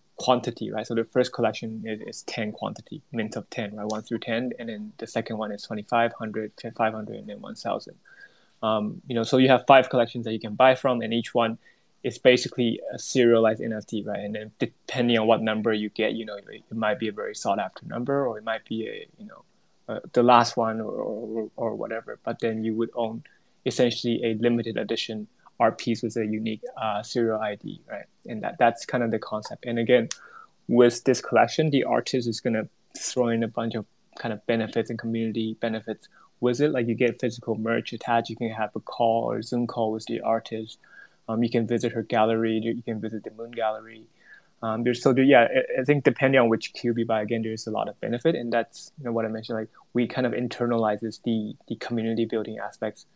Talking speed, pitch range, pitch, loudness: 220 wpm, 110-120 Hz, 115 Hz, -26 LUFS